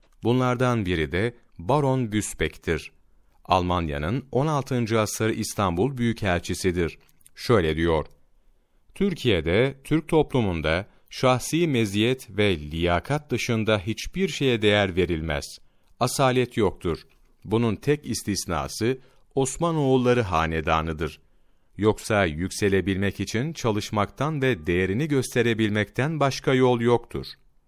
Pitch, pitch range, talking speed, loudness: 110 Hz, 90-130 Hz, 90 wpm, -24 LUFS